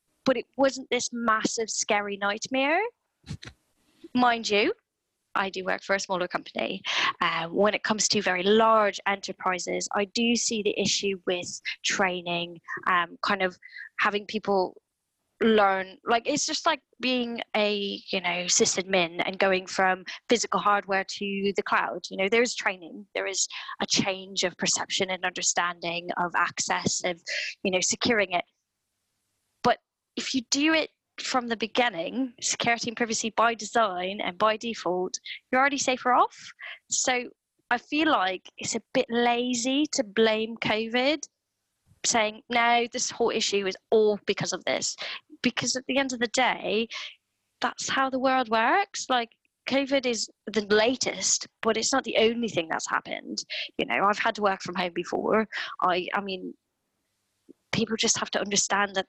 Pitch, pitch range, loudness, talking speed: 220 Hz, 195-245 Hz, -26 LUFS, 160 wpm